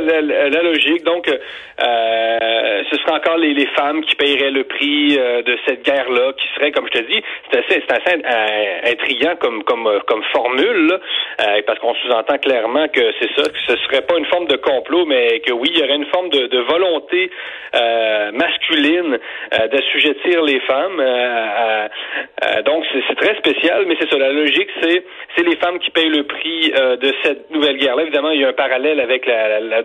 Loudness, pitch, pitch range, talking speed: -15 LUFS, 145 Hz, 125-175 Hz, 210 wpm